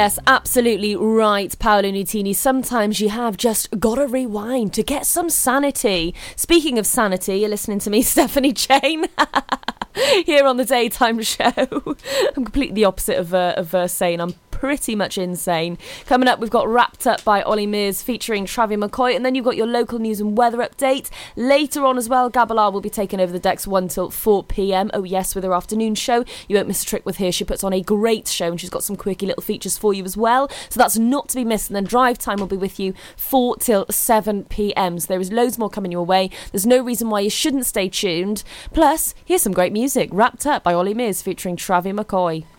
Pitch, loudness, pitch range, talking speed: 215 Hz, -19 LUFS, 195-250 Hz, 220 wpm